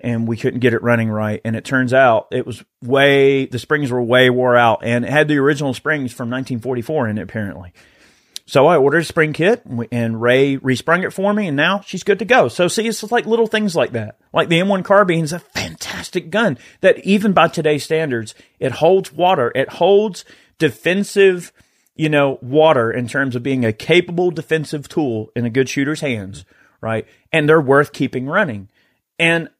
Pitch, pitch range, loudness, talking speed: 140 Hz, 120-170 Hz, -16 LUFS, 205 wpm